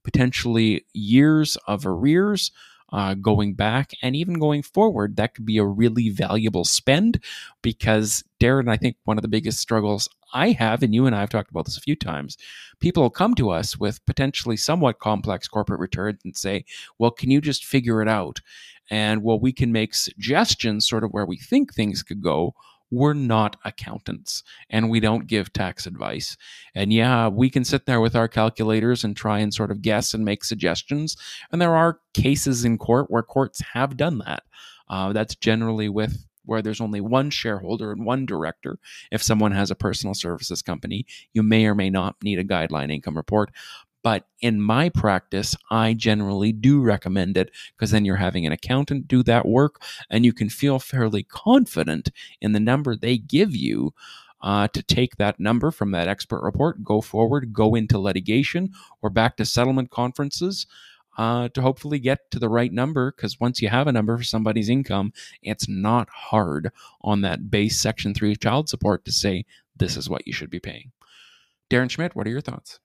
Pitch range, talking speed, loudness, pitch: 105-130 Hz, 190 wpm, -22 LUFS, 110 Hz